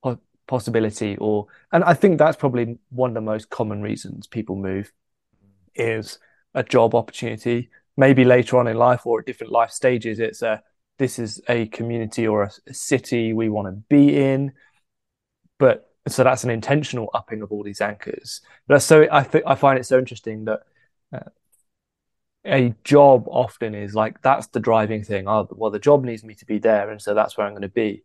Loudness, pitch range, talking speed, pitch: -20 LUFS, 110-130 Hz, 195 wpm, 115 Hz